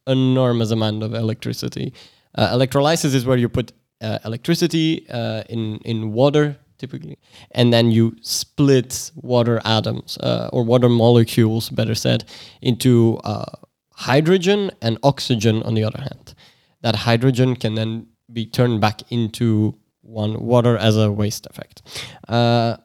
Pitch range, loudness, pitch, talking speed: 110-130 Hz, -19 LUFS, 115 Hz, 140 wpm